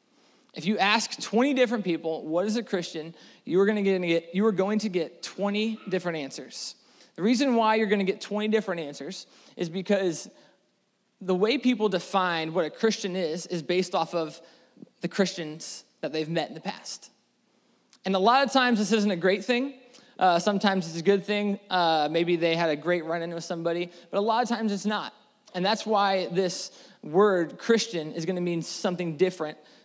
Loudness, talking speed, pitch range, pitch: -27 LUFS, 200 wpm, 170-215 Hz, 190 Hz